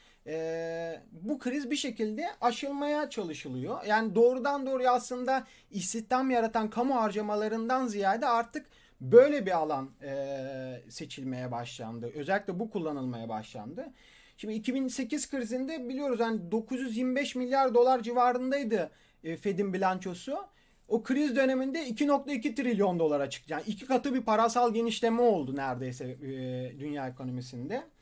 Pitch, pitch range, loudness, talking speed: 225 Hz, 155-260 Hz, -30 LUFS, 120 wpm